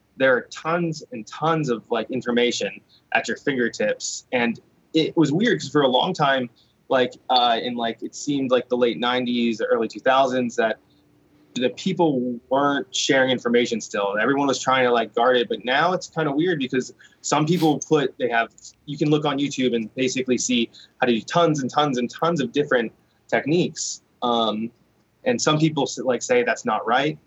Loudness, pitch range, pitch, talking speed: -22 LUFS, 120-150 Hz, 130 Hz, 190 wpm